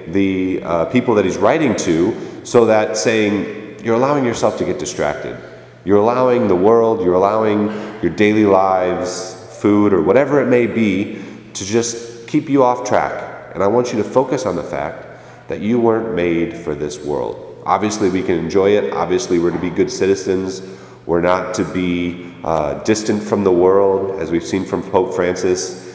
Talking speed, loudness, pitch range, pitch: 185 wpm, -16 LUFS, 90-115 Hz, 100 Hz